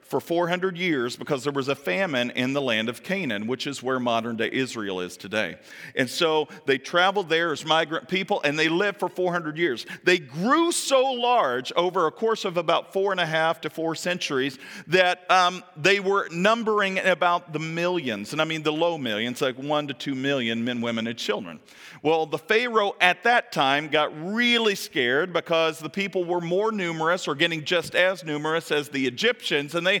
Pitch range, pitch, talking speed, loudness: 145-190 Hz, 170 Hz, 195 wpm, -24 LUFS